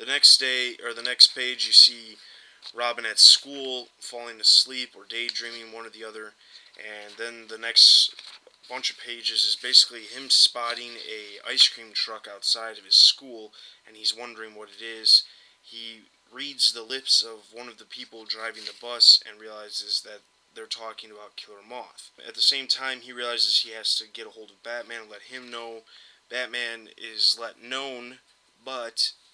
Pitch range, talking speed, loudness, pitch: 110-125 Hz, 180 wpm, -19 LUFS, 115 Hz